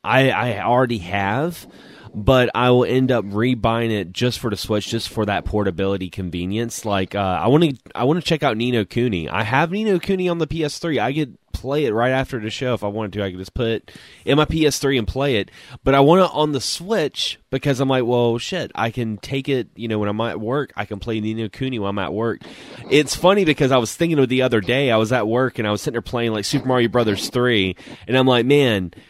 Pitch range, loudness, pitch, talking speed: 105-135 Hz, -20 LUFS, 120 Hz, 255 wpm